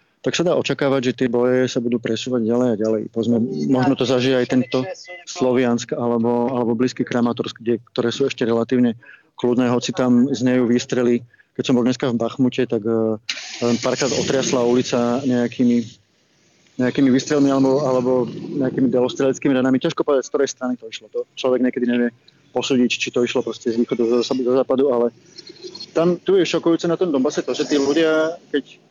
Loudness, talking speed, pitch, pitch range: -19 LUFS, 180 wpm, 125 Hz, 120-135 Hz